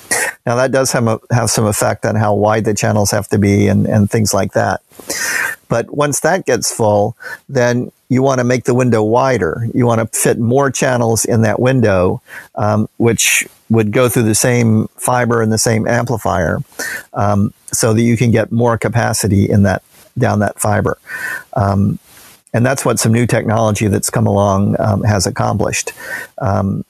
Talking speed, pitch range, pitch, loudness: 185 wpm, 105-120 Hz, 115 Hz, -14 LUFS